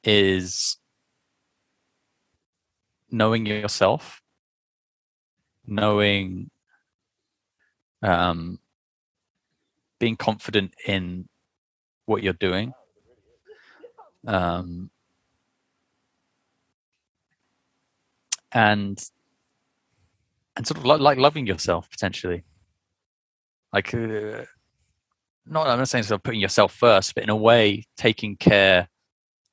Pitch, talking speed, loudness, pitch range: 105 Hz, 75 wpm, -22 LUFS, 95-115 Hz